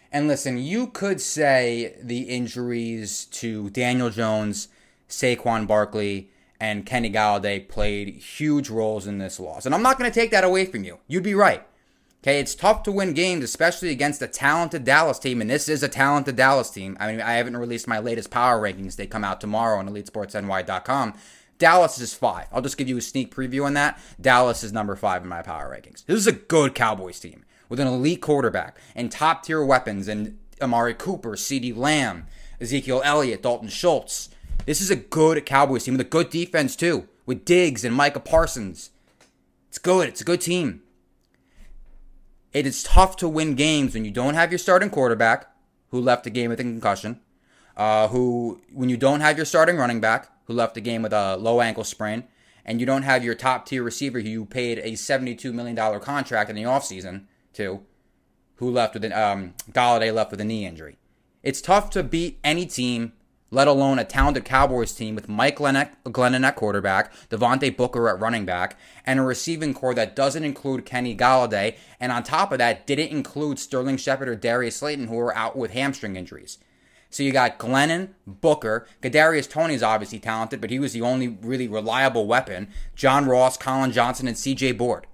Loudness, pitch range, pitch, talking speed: -22 LUFS, 110-140 Hz, 125 Hz, 195 wpm